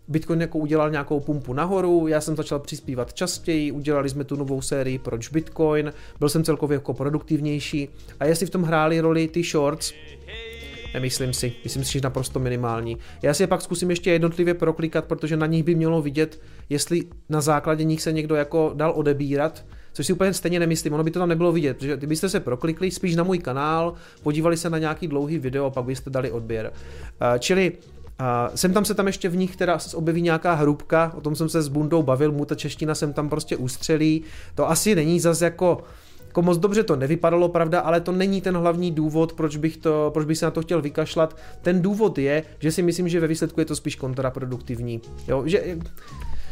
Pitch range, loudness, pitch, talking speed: 140-170 Hz, -23 LUFS, 155 Hz, 205 wpm